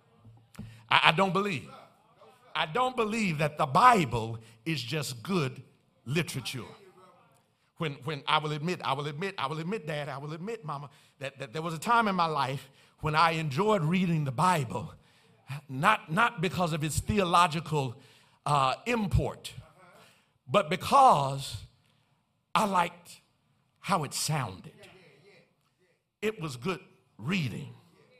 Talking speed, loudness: 135 wpm, -29 LUFS